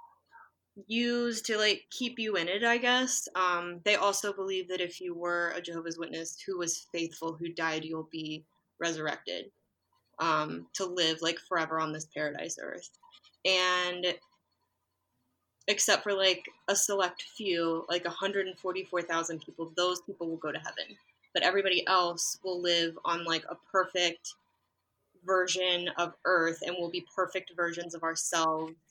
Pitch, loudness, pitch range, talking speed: 175 Hz, -31 LUFS, 165-190 Hz, 150 wpm